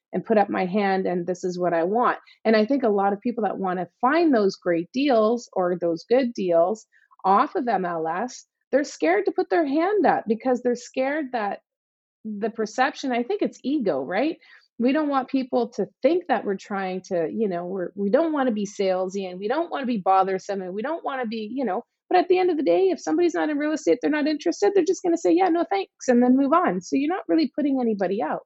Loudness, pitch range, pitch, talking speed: -23 LUFS, 195-305 Hz, 245 Hz, 250 wpm